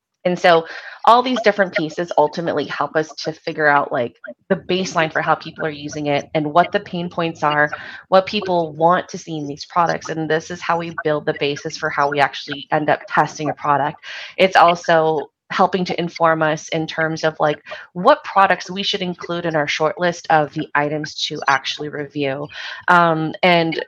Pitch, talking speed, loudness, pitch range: 160 Hz, 200 wpm, -18 LUFS, 150-180 Hz